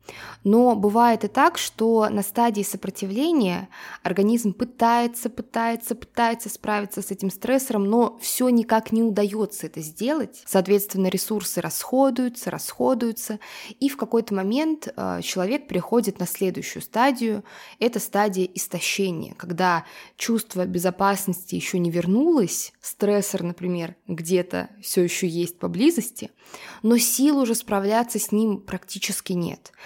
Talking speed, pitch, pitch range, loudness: 120 wpm, 210 Hz, 190-235 Hz, -23 LUFS